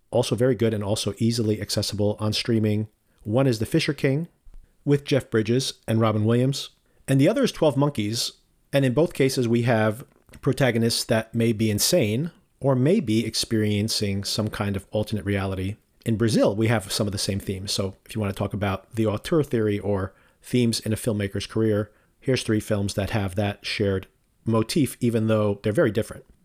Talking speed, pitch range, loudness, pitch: 190 wpm, 105-125 Hz, -24 LUFS, 110 Hz